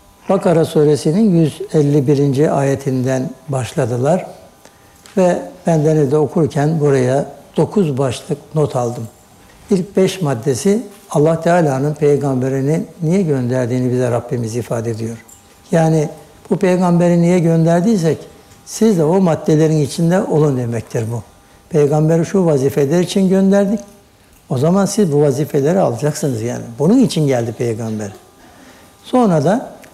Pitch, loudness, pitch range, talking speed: 150 Hz, -15 LUFS, 130-175 Hz, 115 wpm